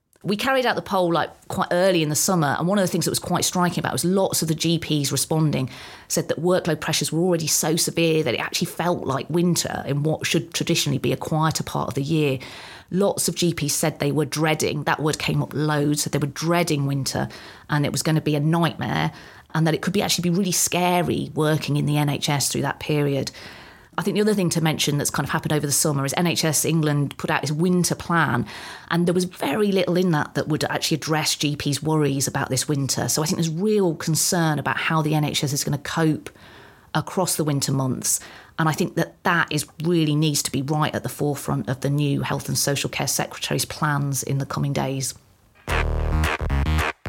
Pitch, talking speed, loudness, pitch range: 155 Hz, 225 wpm, -22 LUFS, 140-170 Hz